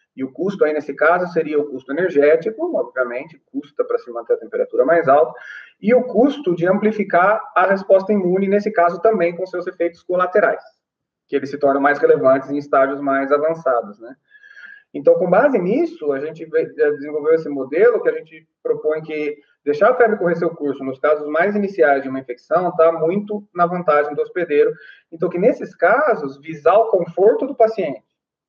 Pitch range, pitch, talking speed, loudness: 150-235 Hz, 180 Hz, 185 wpm, -18 LUFS